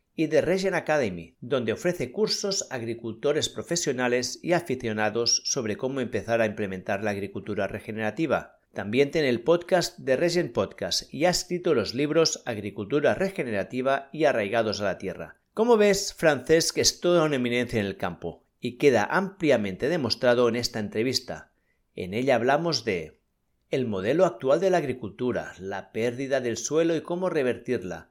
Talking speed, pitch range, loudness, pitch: 155 wpm, 110-165 Hz, -26 LUFS, 125 Hz